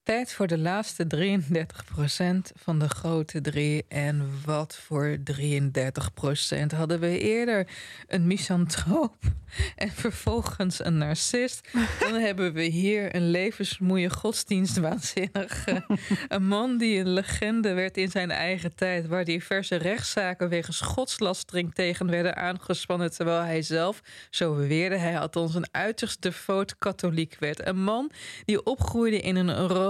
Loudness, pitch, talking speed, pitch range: -27 LUFS, 180 Hz, 130 wpm, 165-195 Hz